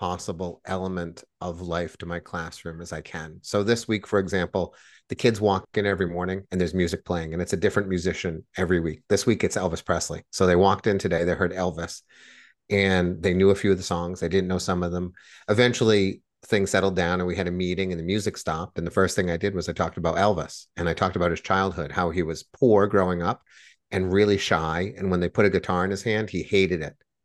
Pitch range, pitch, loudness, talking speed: 85-95 Hz, 90 Hz, -25 LUFS, 240 wpm